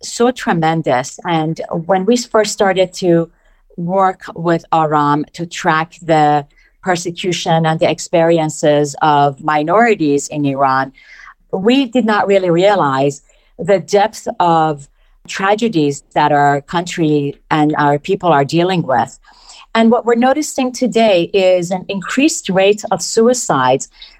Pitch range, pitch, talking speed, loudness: 150-205 Hz, 175 Hz, 125 wpm, -14 LUFS